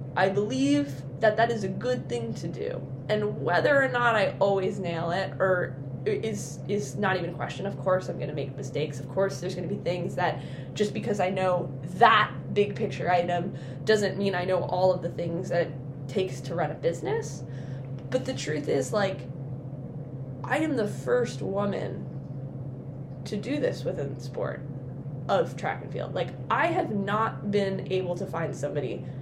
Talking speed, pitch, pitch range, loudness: 190 wpm, 150 Hz, 135-185 Hz, -28 LUFS